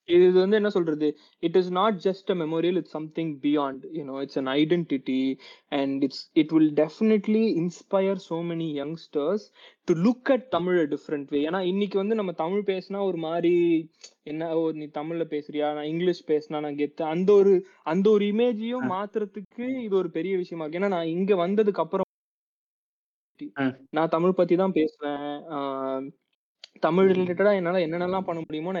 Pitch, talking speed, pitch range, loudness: 175 Hz, 130 wpm, 150-195 Hz, -25 LUFS